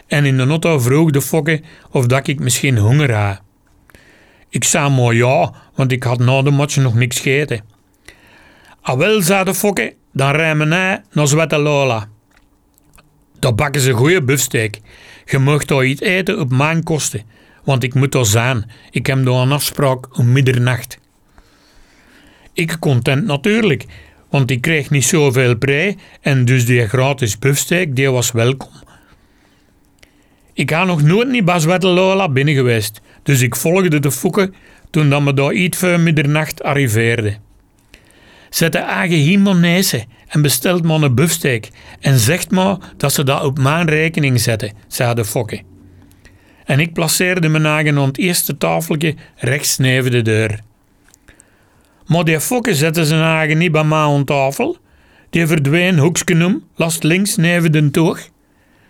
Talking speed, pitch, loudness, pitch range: 155 wpm, 140 Hz, -15 LUFS, 125-165 Hz